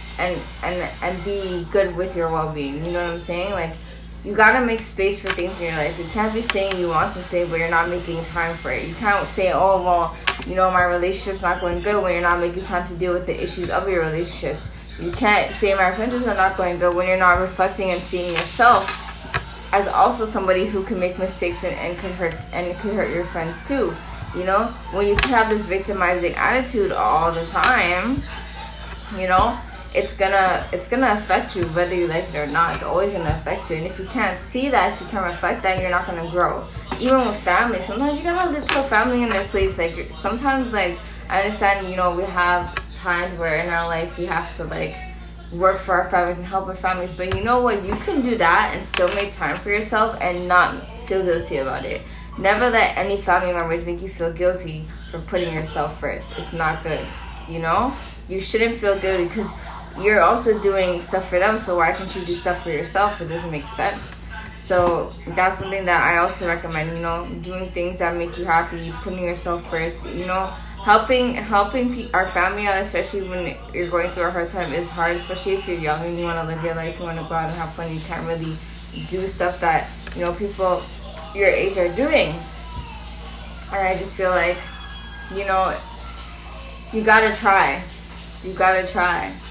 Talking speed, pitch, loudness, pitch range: 215 wpm, 180 Hz, -21 LUFS, 170-195 Hz